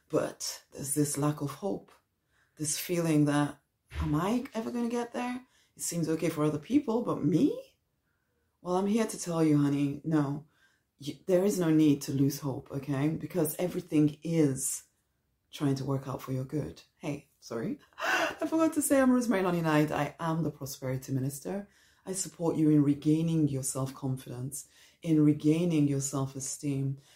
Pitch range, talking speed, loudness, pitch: 140-180 Hz, 170 wpm, -30 LUFS, 150 Hz